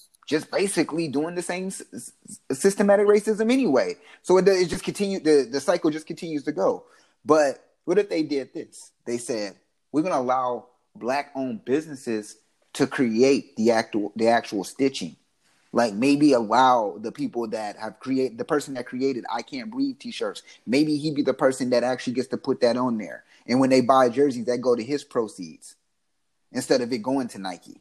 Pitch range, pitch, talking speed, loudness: 125-185 Hz, 140 Hz, 185 wpm, -24 LUFS